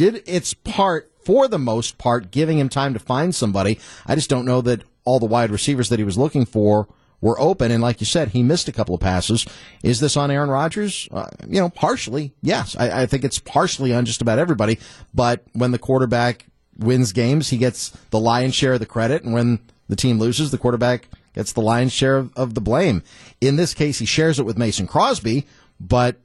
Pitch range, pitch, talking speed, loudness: 115-140 Hz, 125 Hz, 220 wpm, -20 LUFS